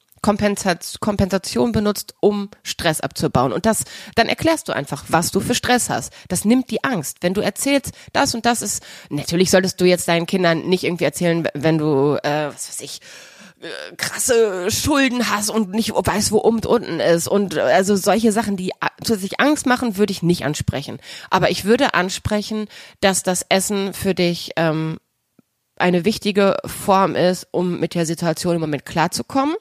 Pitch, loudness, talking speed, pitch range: 195 Hz, -19 LUFS, 180 wpm, 170-220 Hz